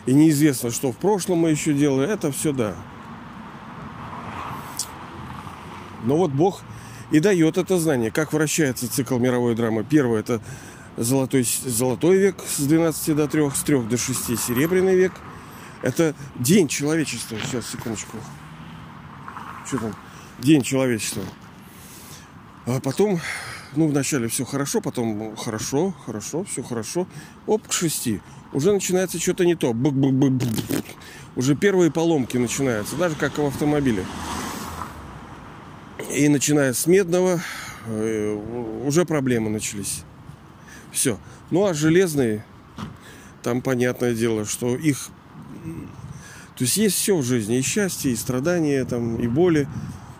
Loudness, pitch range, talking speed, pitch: -22 LUFS, 120-160 Hz, 125 wpm, 135 Hz